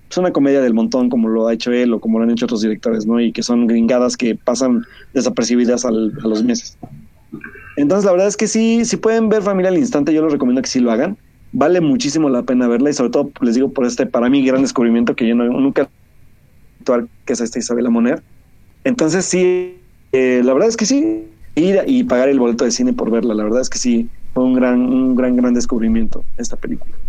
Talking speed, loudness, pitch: 240 wpm, -16 LUFS, 130 Hz